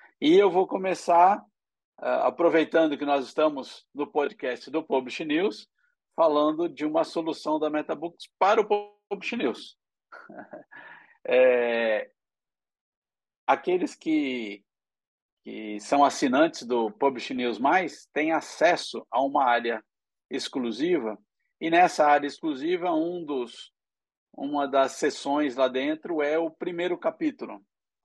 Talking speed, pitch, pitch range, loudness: 120 wpm, 160 Hz, 135-205 Hz, -25 LUFS